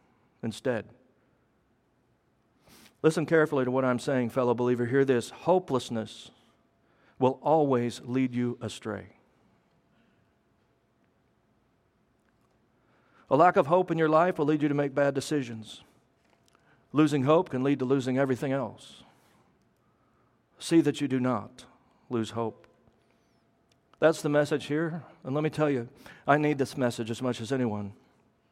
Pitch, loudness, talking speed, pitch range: 135 Hz, -27 LUFS, 135 wpm, 125-150 Hz